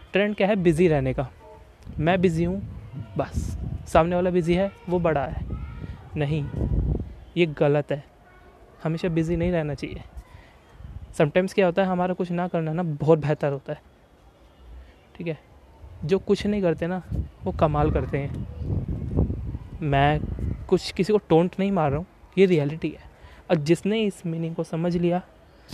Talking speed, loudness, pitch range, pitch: 160 wpm, -25 LUFS, 145-180 Hz, 165 Hz